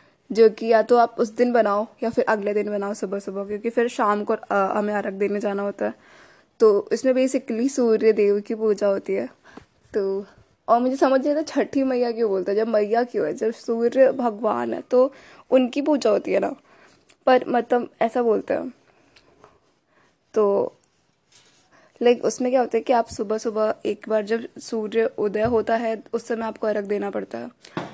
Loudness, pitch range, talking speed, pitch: -22 LUFS, 210-250 Hz, 190 wpm, 230 Hz